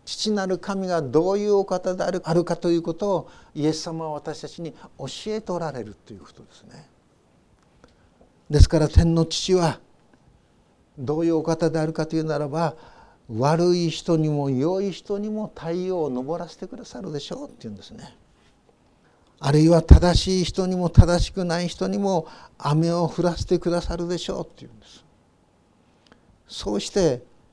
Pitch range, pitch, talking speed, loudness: 155-180 Hz, 170 Hz, 310 characters per minute, -23 LUFS